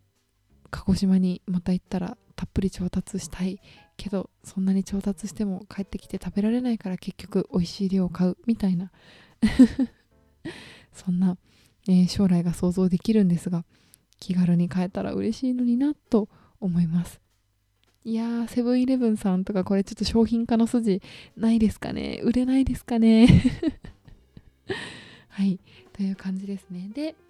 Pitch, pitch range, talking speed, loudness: 195 Hz, 180-225 Hz, 310 characters per minute, -25 LUFS